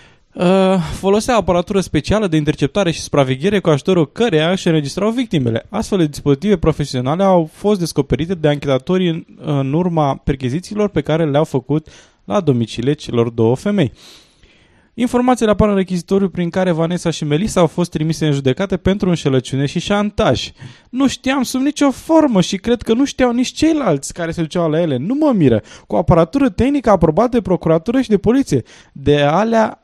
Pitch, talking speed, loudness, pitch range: 180 Hz, 170 wpm, -16 LUFS, 150-210 Hz